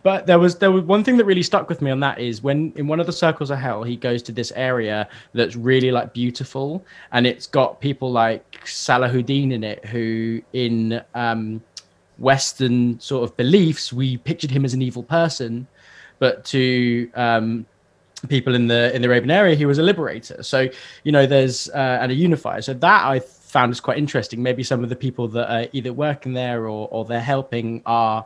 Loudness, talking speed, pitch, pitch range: -20 LUFS, 210 wpm, 125 Hz, 120-140 Hz